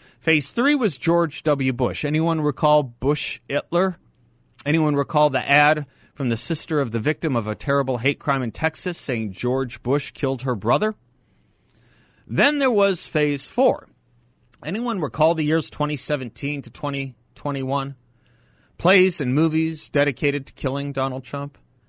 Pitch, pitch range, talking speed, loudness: 145 Hz, 125-155 Hz, 145 wpm, -22 LUFS